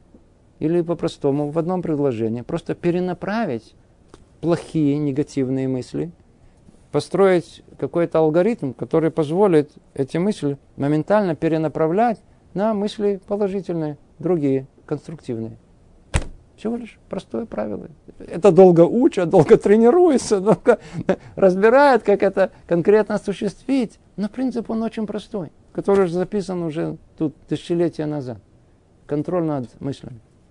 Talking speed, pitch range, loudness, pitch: 105 wpm, 145-205 Hz, -20 LUFS, 170 Hz